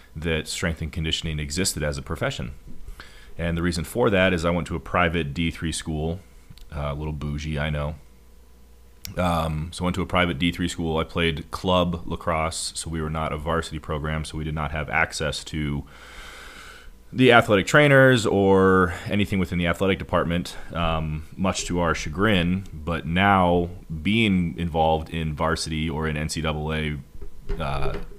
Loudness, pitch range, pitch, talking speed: -23 LUFS, 75-90 Hz, 80 Hz, 165 wpm